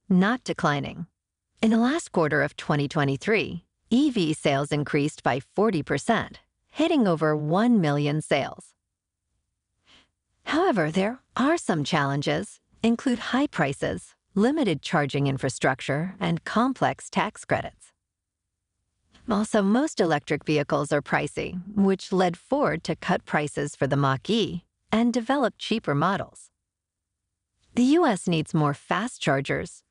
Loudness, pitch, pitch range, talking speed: -25 LUFS, 160 Hz, 140-220 Hz, 115 wpm